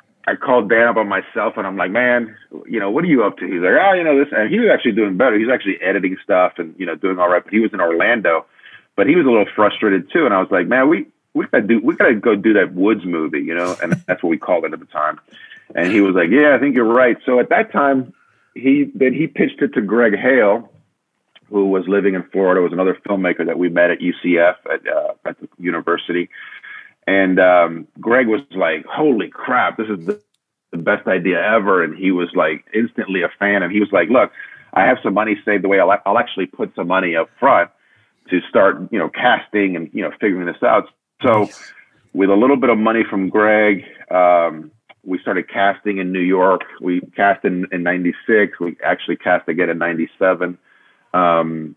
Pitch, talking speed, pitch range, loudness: 100 Hz, 230 wpm, 90-125 Hz, -16 LUFS